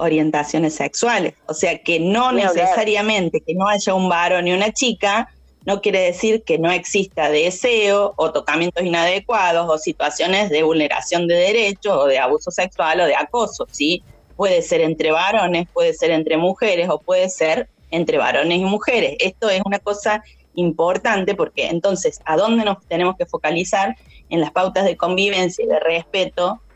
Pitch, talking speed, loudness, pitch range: 180 Hz, 170 wpm, -18 LUFS, 165-205 Hz